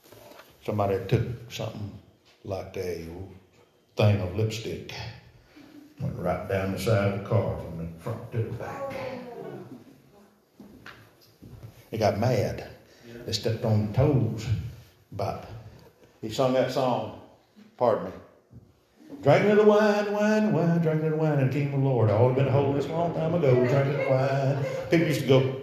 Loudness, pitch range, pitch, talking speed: -26 LUFS, 110-140 Hz, 120 Hz, 160 wpm